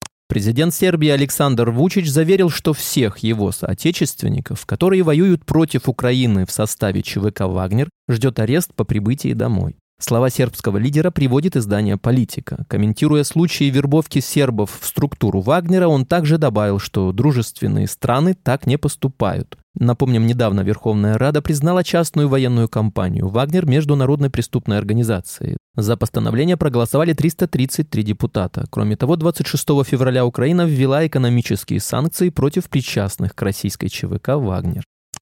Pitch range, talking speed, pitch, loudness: 110-155 Hz, 130 wpm, 130 Hz, -18 LUFS